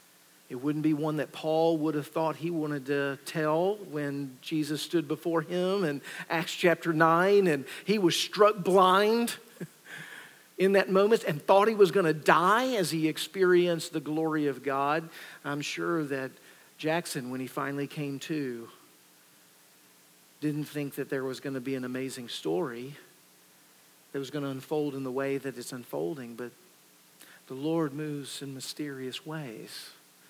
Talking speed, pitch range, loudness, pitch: 160 wpm, 135-165 Hz, -29 LUFS, 150 Hz